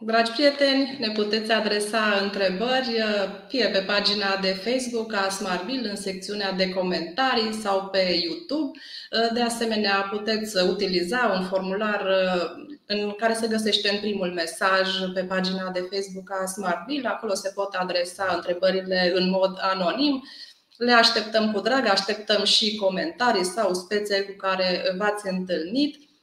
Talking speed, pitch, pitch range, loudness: 140 wpm, 200 Hz, 190-225 Hz, -24 LUFS